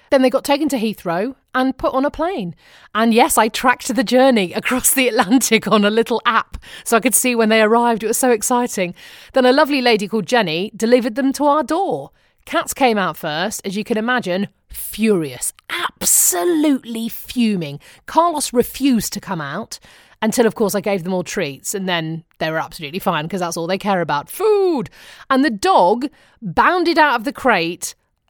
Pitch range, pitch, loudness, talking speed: 195-265 Hz, 230 Hz, -17 LUFS, 195 wpm